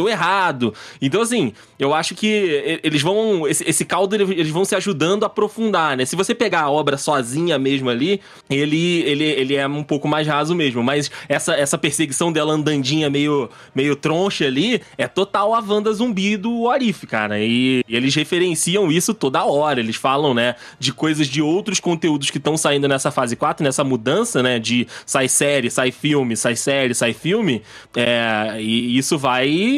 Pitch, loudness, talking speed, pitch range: 150 Hz, -18 LUFS, 185 wpm, 135-190 Hz